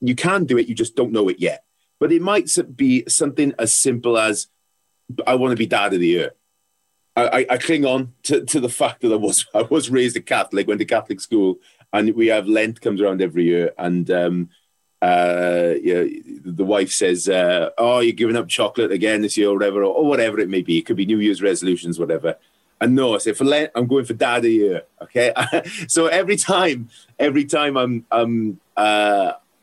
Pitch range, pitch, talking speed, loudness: 105-165 Hz, 120 Hz, 225 wpm, -19 LUFS